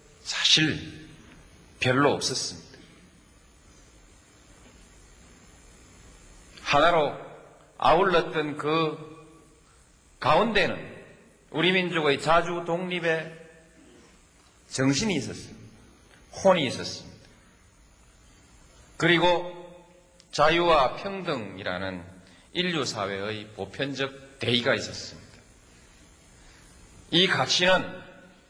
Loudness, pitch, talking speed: -25 LUFS, 135 Hz, 160 characters per minute